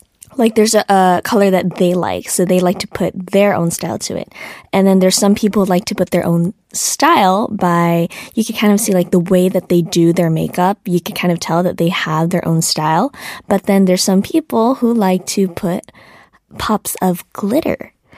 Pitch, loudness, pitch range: 185 Hz, -14 LUFS, 175-200 Hz